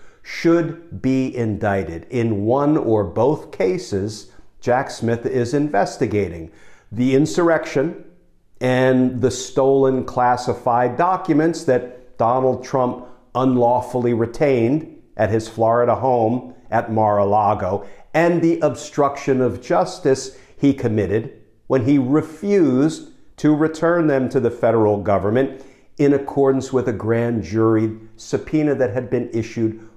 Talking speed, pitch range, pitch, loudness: 120 wpm, 115-140 Hz, 125 Hz, -19 LUFS